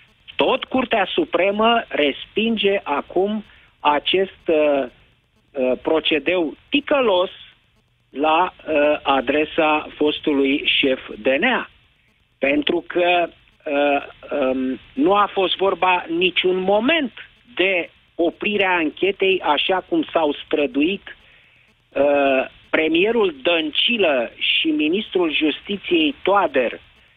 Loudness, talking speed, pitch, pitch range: -19 LUFS, 90 wpm, 175 Hz, 145-230 Hz